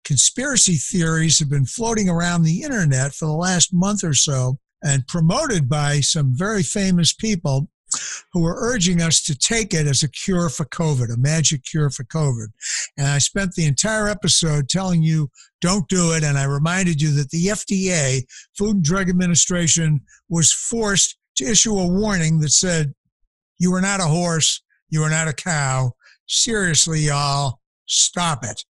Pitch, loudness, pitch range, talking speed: 165 Hz, -18 LUFS, 145-185 Hz, 170 wpm